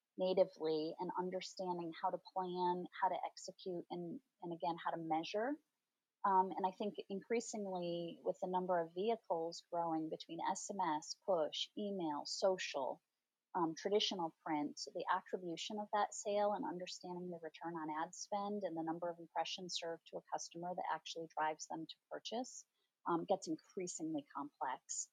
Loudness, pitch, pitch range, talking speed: -42 LUFS, 180 Hz, 165-205 Hz, 155 wpm